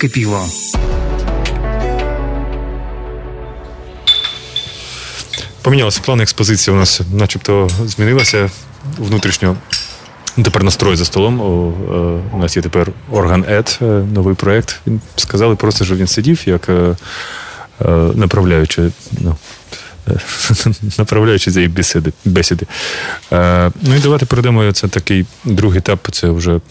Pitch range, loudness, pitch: 85-110 Hz, -13 LUFS, 100 Hz